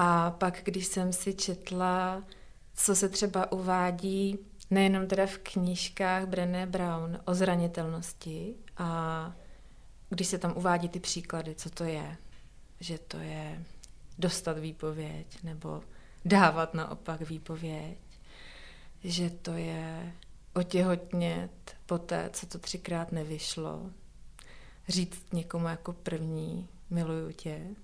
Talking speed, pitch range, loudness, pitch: 115 wpm, 165-185 Hz, -32 LUFS, 175 Hz